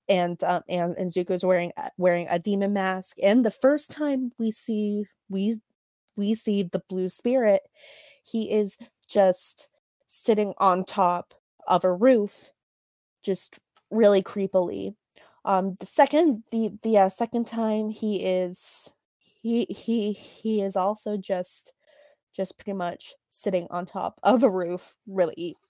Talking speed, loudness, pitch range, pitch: 140 wpm, -25 LUFS, 185-225 Hz, 200 Hz